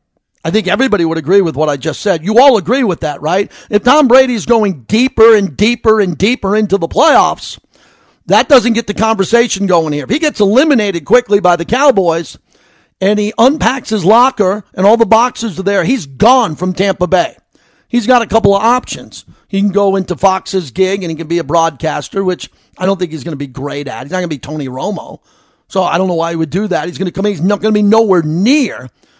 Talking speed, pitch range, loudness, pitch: 235 wpm, 170-225 Hz, -12 LUFS, 200 Hz